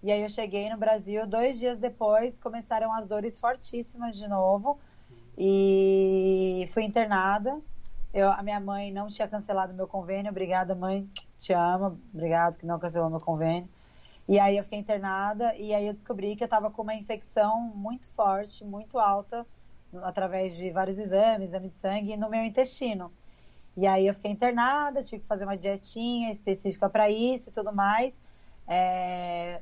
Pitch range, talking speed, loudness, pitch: 190-225 Hz, 170 wpm, -28 LUFS, 205 Hz